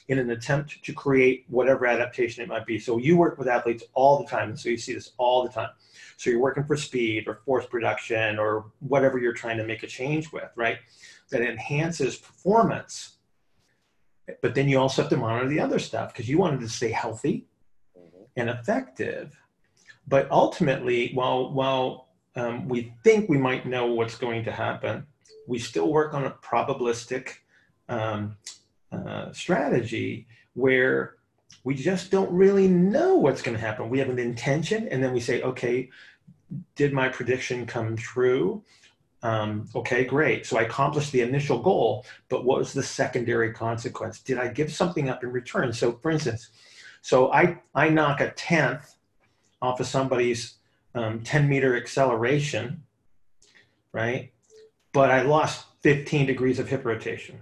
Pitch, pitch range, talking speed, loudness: 130 Hz, 115-140 Hz, 165 wpm, -25 LUFS